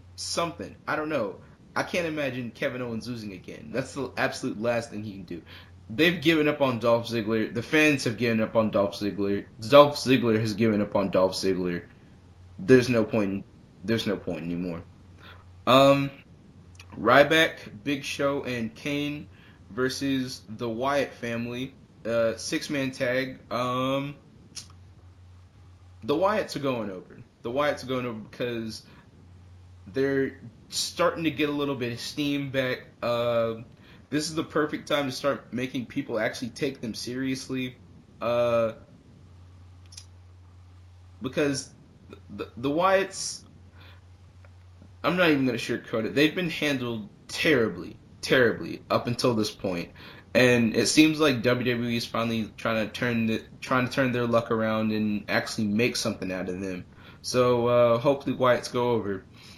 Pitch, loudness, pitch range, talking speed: 115 Hz, -26 LUFS, 95-130 Hz, 150 wpm